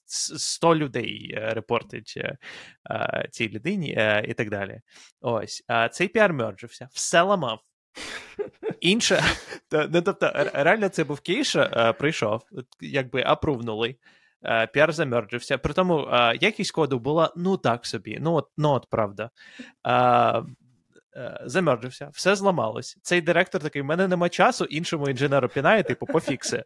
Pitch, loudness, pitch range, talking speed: 140 Hz, -24 LUFS, 120-175 Hz, 130 wpm